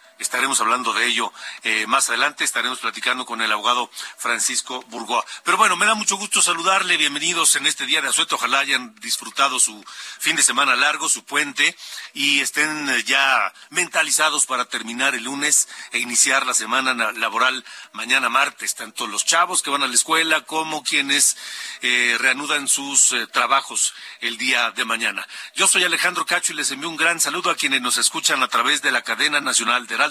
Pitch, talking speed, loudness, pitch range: 140 Hz, 190 wpm, -18 LUFS, 125-155 Hz